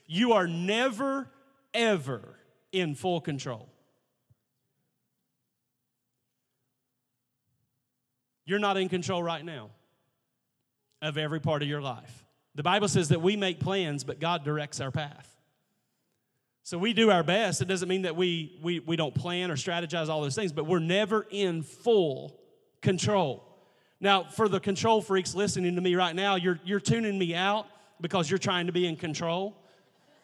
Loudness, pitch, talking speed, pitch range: -28 LUFS, 170 Hz, 155 wpm, 135-195 Hz